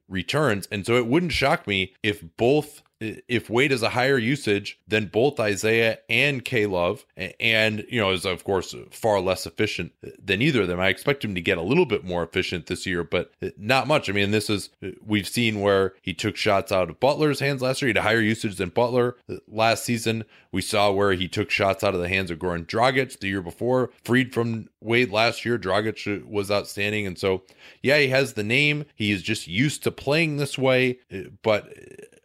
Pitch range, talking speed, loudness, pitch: 95-125 Hz, 210 wpm, -23 LUFS, 110 Hz